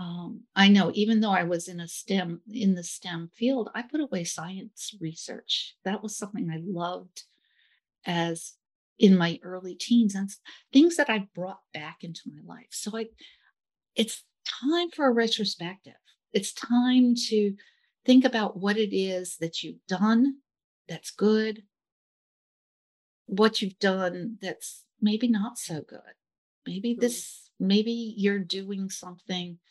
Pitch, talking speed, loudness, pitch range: 205 Hz, 145 wpm, -27 LUFS, 180-230 Hz